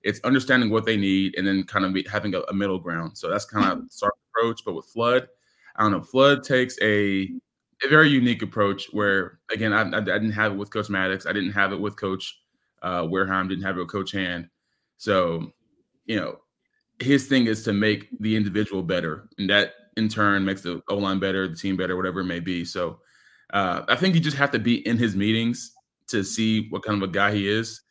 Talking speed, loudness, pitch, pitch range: 230 wpm, -23 LUFS, 100 Hz, 95-115 Hz